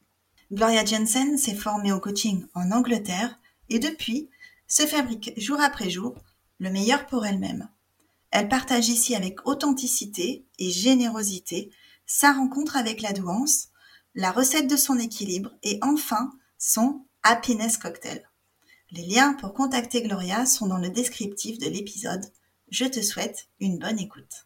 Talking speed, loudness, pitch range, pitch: 140 wpm, -24 LUFS, 200-265 Hz, 230 Hz